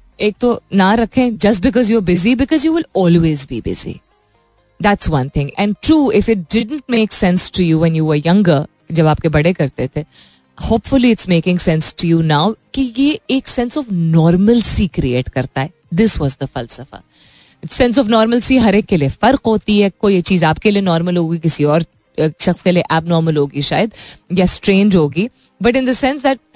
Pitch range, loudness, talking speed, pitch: 155-225 Hz, -14 LUFS, 195 wpm, 180 Hz